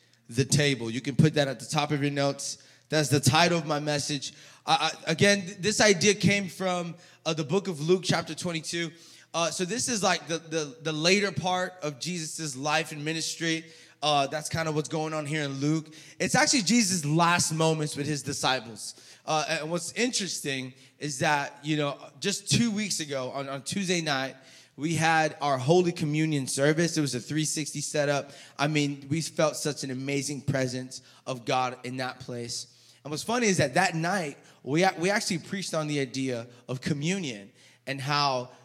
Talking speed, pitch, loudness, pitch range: 190 wpm, 155 Hz, -27 LUFS, 140-170 Hz